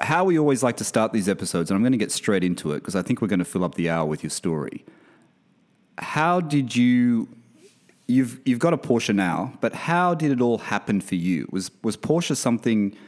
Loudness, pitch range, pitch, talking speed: -23 LUFS, 95-140 Hz, 115 Hz, 230 wpm